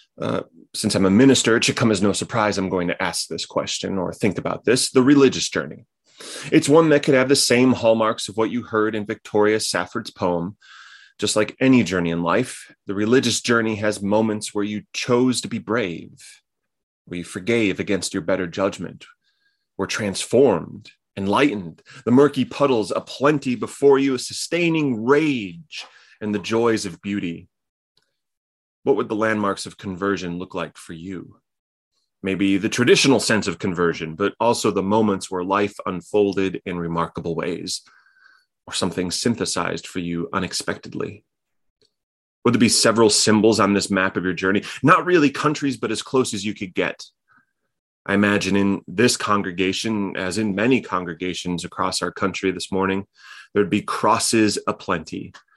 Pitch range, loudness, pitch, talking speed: 95-120 Hz, -20 LUFS, 105 Hz, 165 wpm